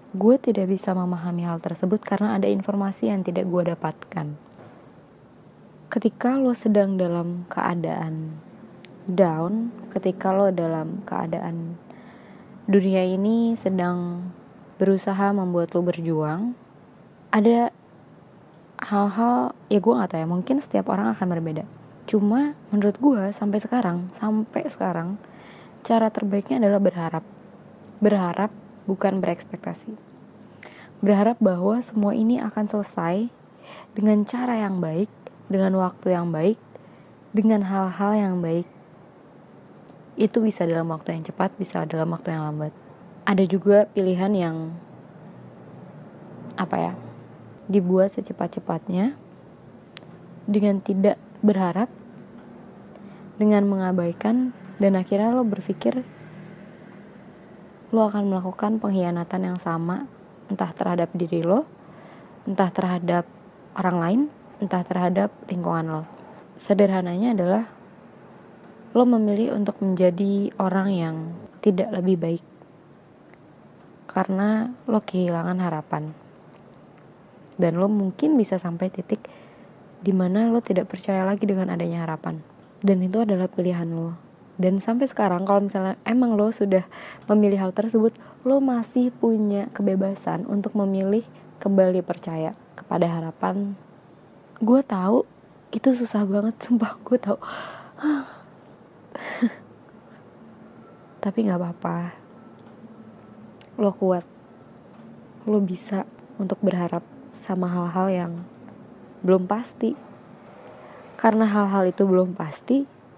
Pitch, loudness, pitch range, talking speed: 200 Hz, -23 LUFS, 180-215 Hz, 105 wpm